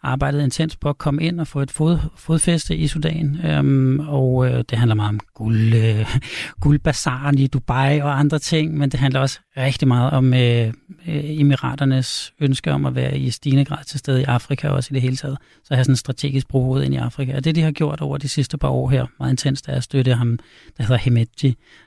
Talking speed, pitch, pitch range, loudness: 240 wpm, 135 Hz, 130-145 Hz, -19 LUFS